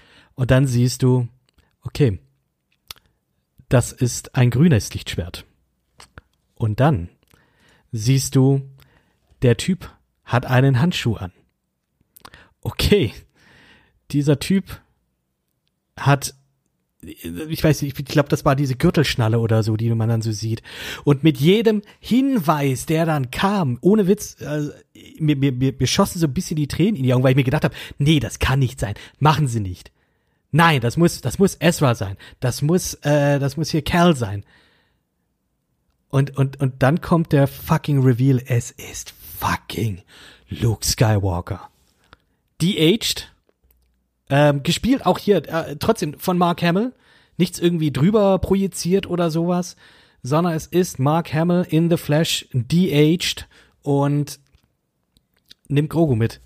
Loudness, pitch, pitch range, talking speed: -19 LUFS, 145 Hz, 120-165 Hz, 140 wpm